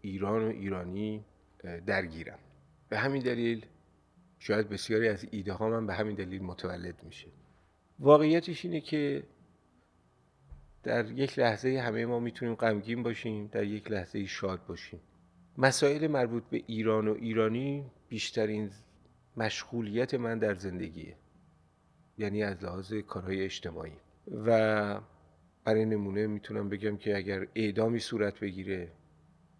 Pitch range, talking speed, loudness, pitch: 95-115 Hz, 120 wpm, -32 LUFS, 105 Hz